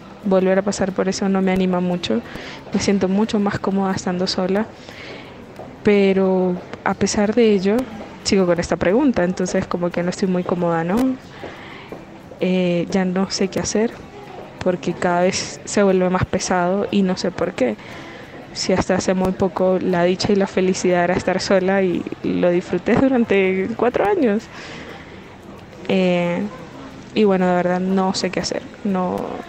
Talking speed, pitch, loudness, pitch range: 165 wpm, 190 Hz, -19 LUFS, 180-205 Hz